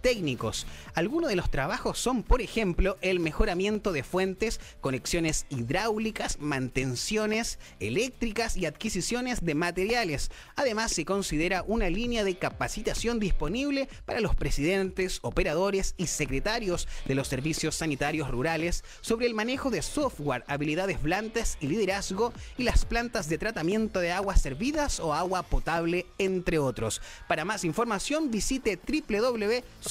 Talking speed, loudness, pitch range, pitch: 130 wpm, -29 LUFS, 155-225 Hz, 190 Hz